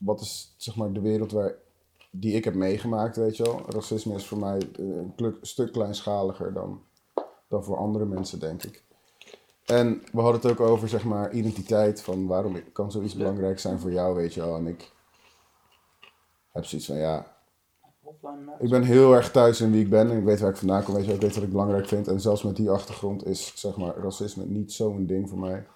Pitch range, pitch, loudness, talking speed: 95-110 Hz, 105 Hz, -26 LUFS, 210 wpm